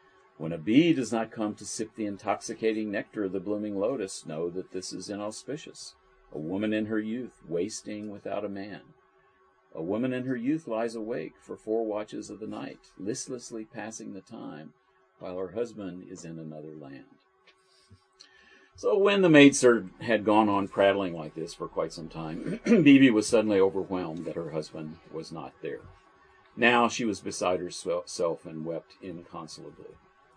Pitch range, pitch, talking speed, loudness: 95-115 Hz, 105 Hz, 170 wpm, -28 LUFS